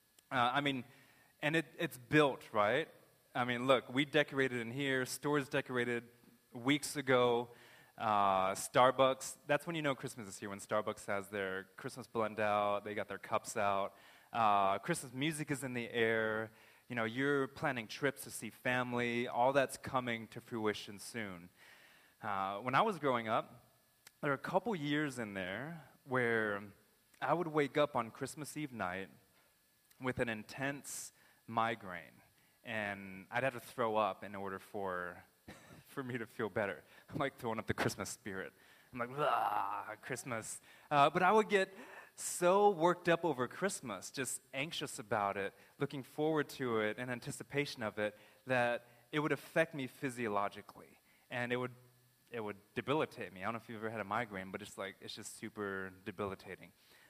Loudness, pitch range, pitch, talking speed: -37 LUFS, 105-140 Hz, 120 Hz, 170 wpm